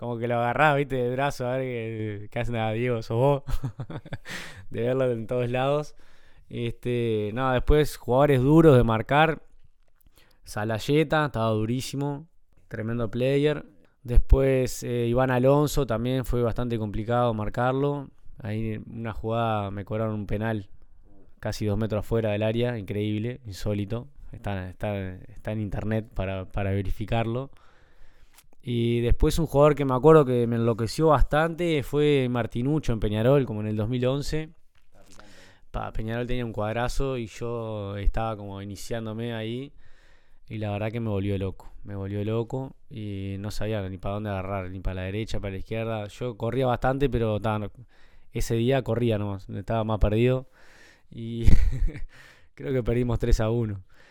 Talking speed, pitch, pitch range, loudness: 150 wpm, 115 Hz, 105-130 Hz, -26 LUFS